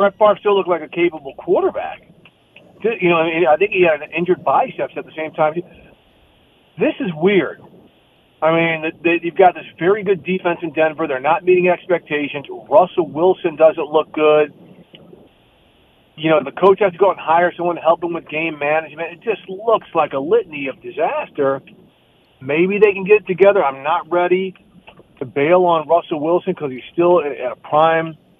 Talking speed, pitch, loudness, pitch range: 190 wpm, 170 Hz, -17 LUFS, 160-185 Hz